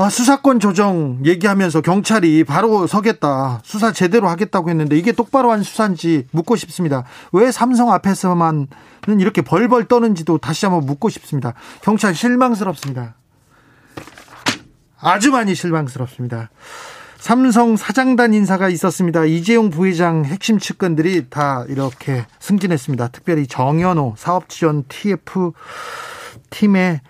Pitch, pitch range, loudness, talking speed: 180 Hz, 150-220 Hz, -16 LUFS, 310 characters per minute